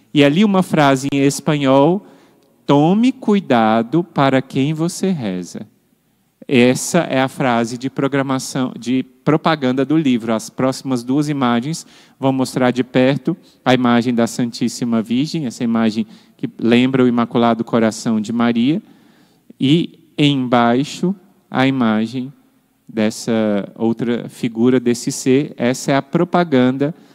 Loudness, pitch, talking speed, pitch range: -17 LUFS, 130 Hz, 125 wpm, 120-155 Hz